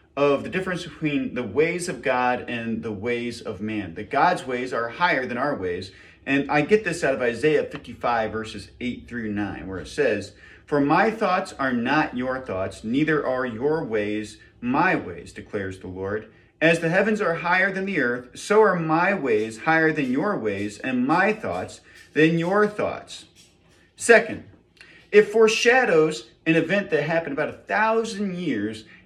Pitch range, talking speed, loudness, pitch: 115-180 Hz, 175 wpm, -23 LUFS, 145 Hz